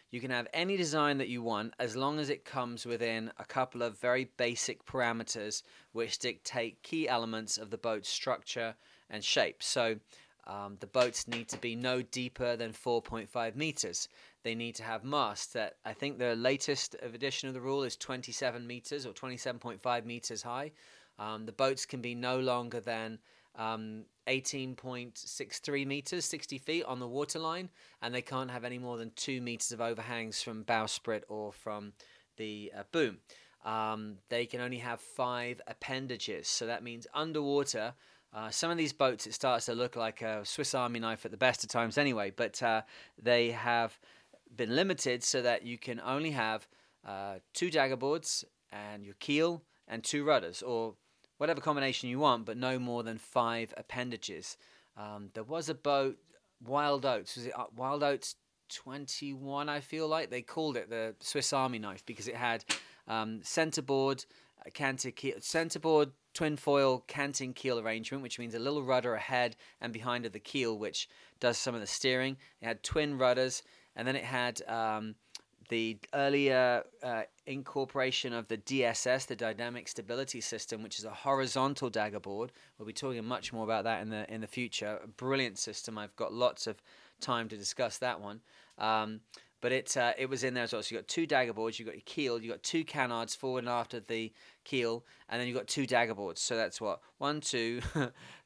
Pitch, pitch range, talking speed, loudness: 120 Hz, 115-135 Hz, 185 wpm, -35 LUFS